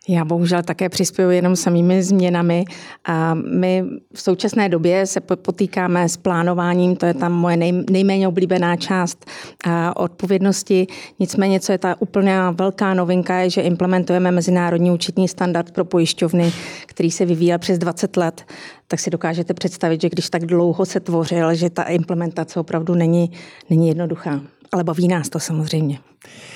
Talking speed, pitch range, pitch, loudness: 155 wpm, 170-185 Hz, 175 Hz, -18 LUFS